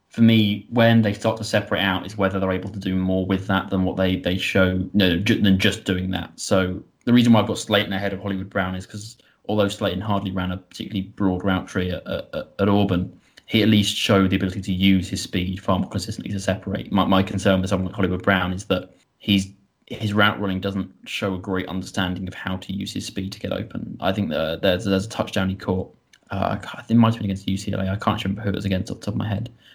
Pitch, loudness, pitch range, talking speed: 95 Hz, -22 LUFS, 95-105 Hz, 260 wpm